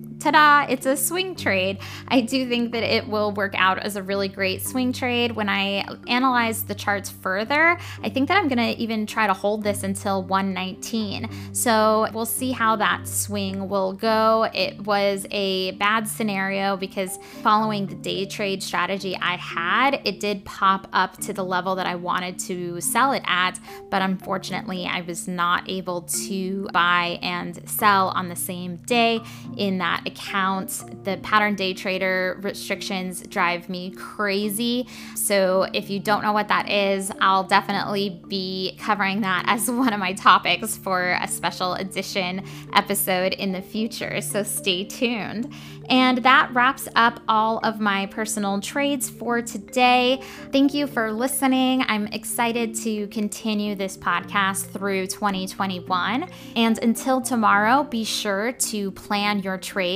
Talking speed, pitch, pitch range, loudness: 160 wpm, 200 Hz, 190-225 Hz, -22 LUFS